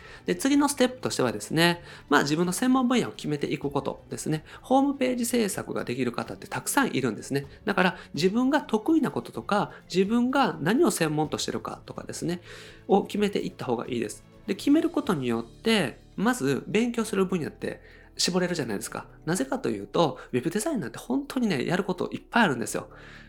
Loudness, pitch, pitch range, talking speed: -27 LUFS, 195 Hz, 150-245 Hz, 430 characters per minute